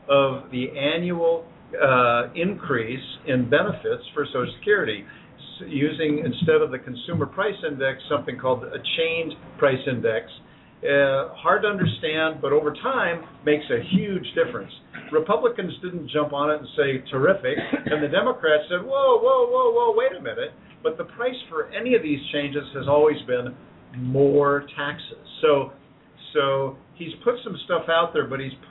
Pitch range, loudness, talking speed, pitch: 135-180 Hz, -23 LUFS, 160 wpm, 150 Hz